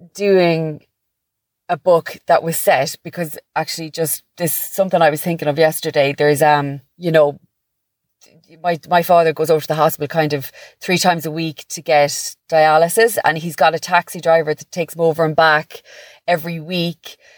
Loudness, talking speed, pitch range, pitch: -17 LUFS, 175 wpm, 155-175 Hz, 160 Hz